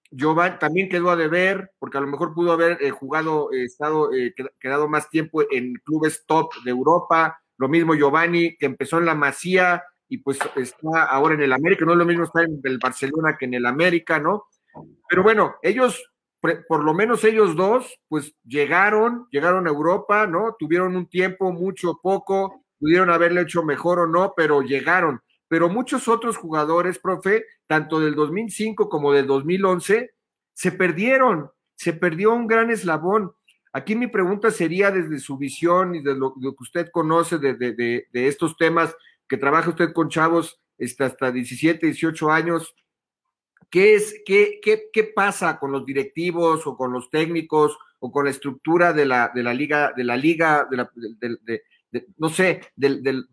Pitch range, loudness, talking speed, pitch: 145-185 Hz, -20 LUFS, 185 wpm, 165 Hz